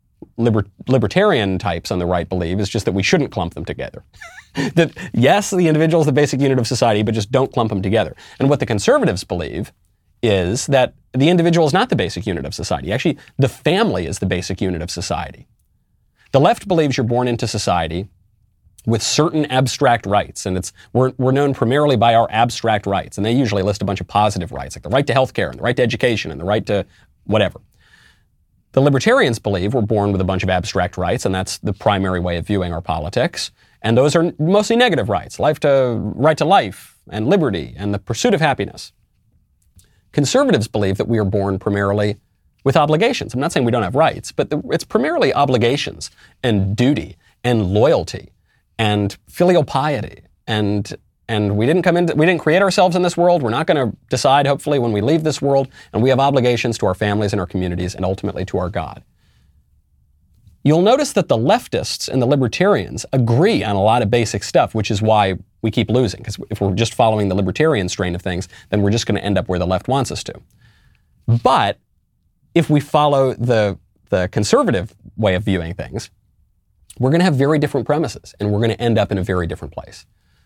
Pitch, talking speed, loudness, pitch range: 105 Hz, 205 wpm, -17 LUFS, 95-135 Hz